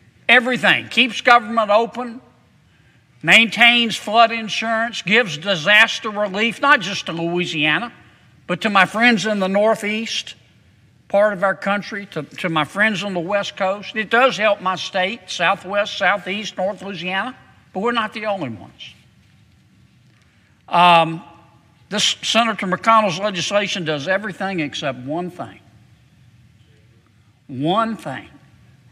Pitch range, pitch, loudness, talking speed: 150-220 Hz, 195 Hz, -17 LUFS, 125 wpm